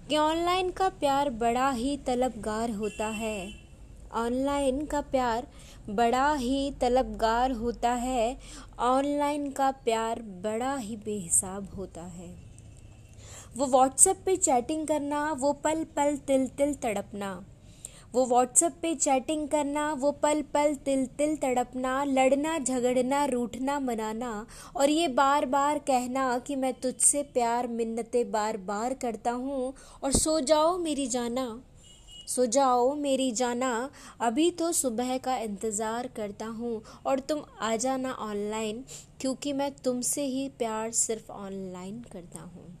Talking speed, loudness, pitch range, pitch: 135 wpm, -28 LUFS, 225-285 Hz, 255 Hz